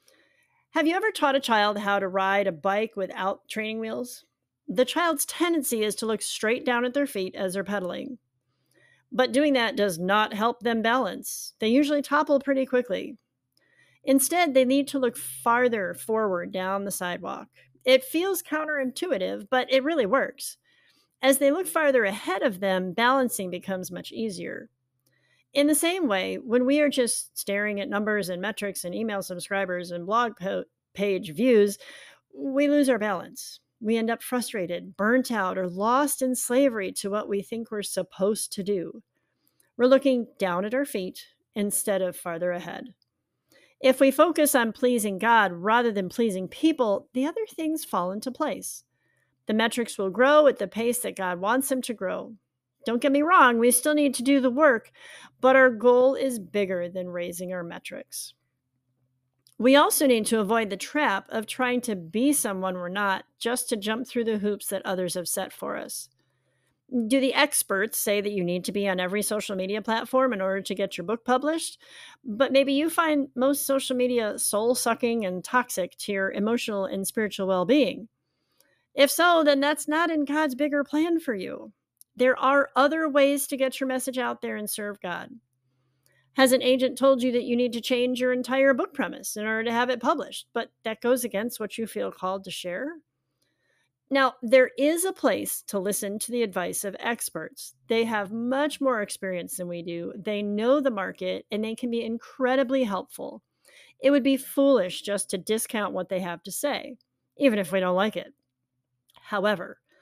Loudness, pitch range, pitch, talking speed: -25 LUFS, 195-270 Hz, 230 Hz, 185 wpm